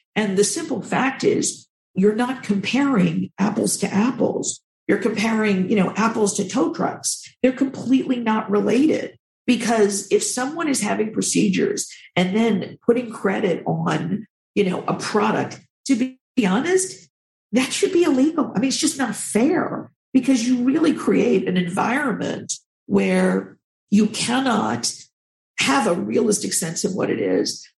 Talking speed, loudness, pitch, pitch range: 145 wpm, -21 LUFS, 230 Hz, 205-265 Hz